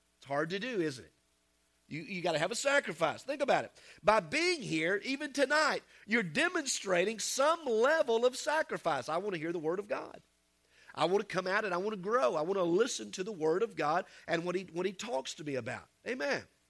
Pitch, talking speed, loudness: 195 Hz, 225 wpm, -33 LUFS